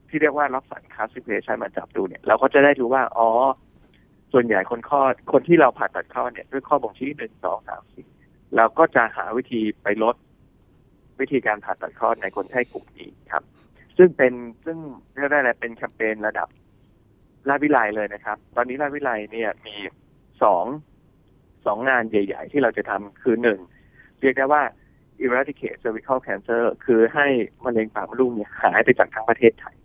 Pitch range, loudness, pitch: 110-140 Hz, -21 LUFS, 120 Hz